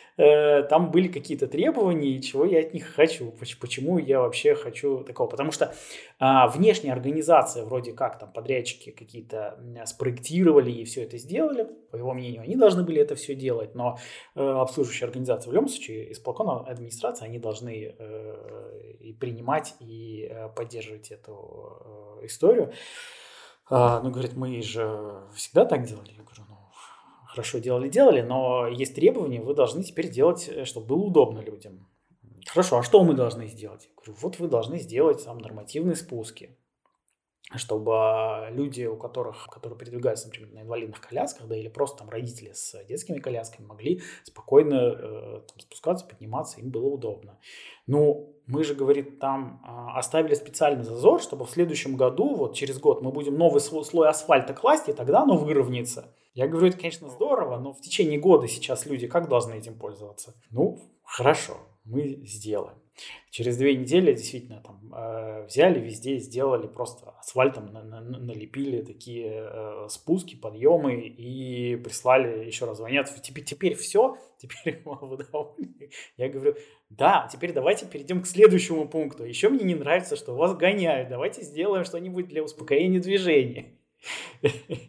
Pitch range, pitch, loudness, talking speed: 115-170 Hz, 135 Hz, -25 LUFS, 150 wpm